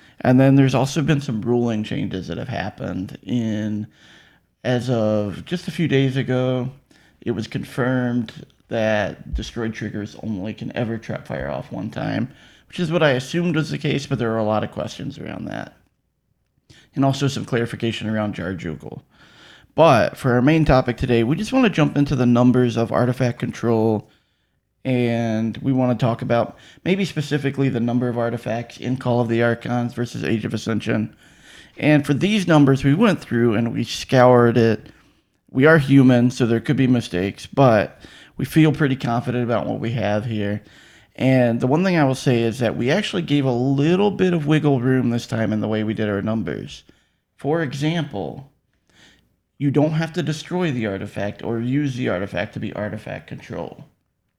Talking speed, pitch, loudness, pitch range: 185 wpm, 125 Hz, -20 LUFS, 115-140 Hz